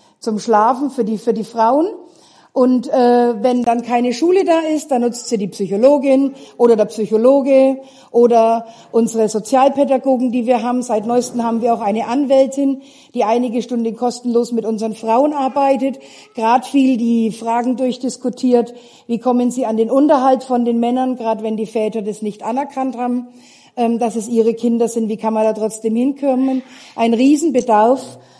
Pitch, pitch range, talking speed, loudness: 245 Hz, 230-265 Hz, 170 wpm, -16 LUFS